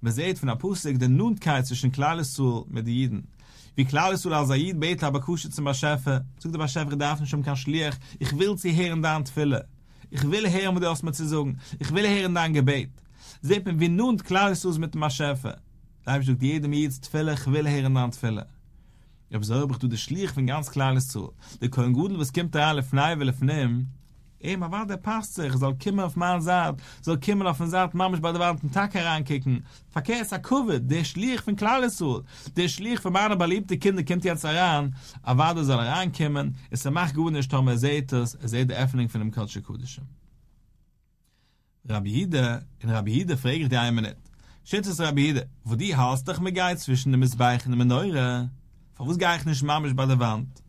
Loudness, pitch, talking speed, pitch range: -26 LUFS, 145 Hz, 200 wpm, 130-175 Hz